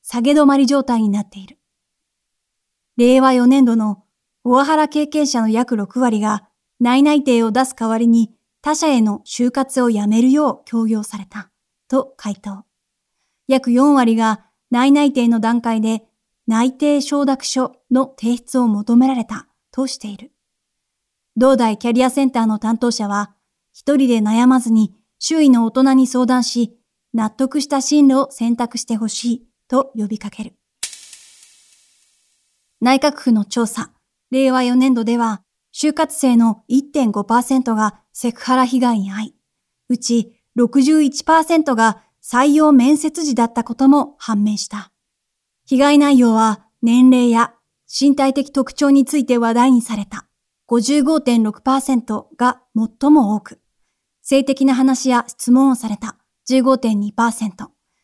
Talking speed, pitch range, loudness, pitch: 225 characters per minute, 225-270 Hz, -16 LUFS, 245 Hz